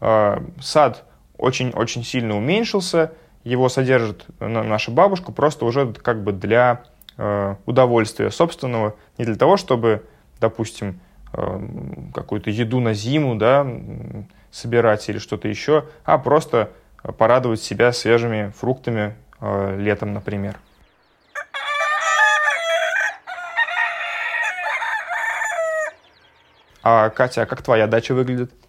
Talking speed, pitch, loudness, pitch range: 90 wpm, 120 Hz, -20 LUFS, 105-145 Hz